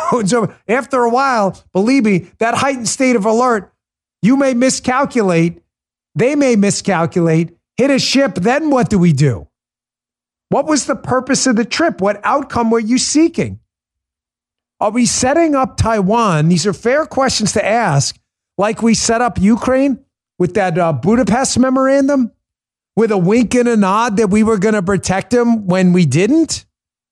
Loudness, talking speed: -14 LUFS, 160 wpm